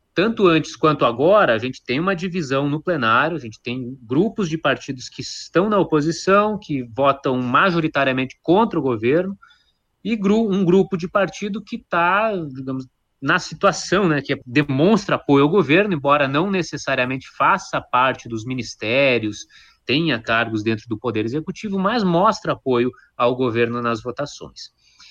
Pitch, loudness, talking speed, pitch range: 150 Hz, -19 LUFS, 155 wpm, 125-190 Hz